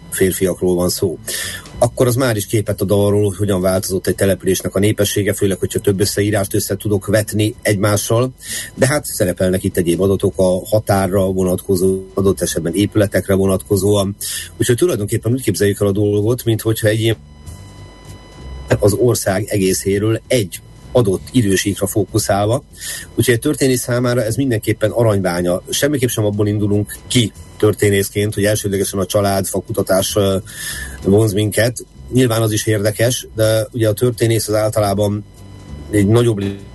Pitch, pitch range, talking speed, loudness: 105 Hz, 95-110 Hz, 145 wpm, -16 LUFS